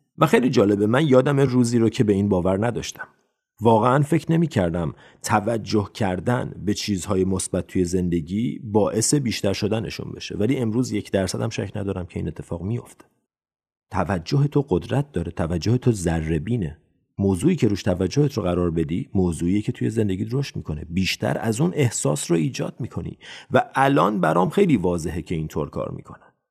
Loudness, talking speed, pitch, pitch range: -22 LUFS, 175 wpm, 105 Hz, 90-125 Hz